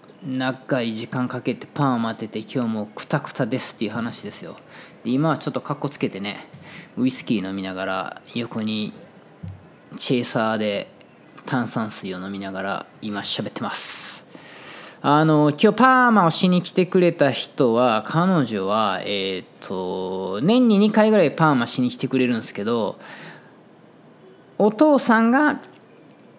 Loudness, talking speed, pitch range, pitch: -21 LUFS, 290 characters per minute, 105-165 Hz, 130 Hz